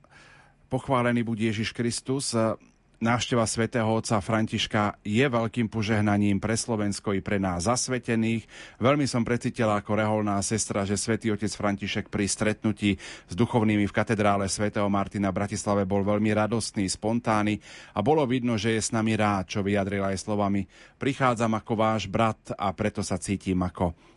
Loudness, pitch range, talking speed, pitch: -26 LUFS, 100-115 Hz, 155 wpm, 110 Hz